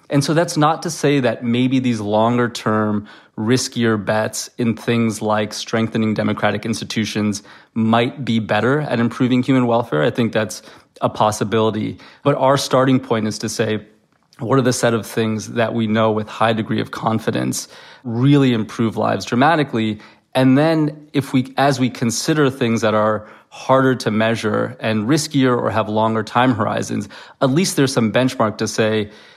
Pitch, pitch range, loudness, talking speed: 115 Hz, 110-130 Hz, -18 LUFS, 170 wpm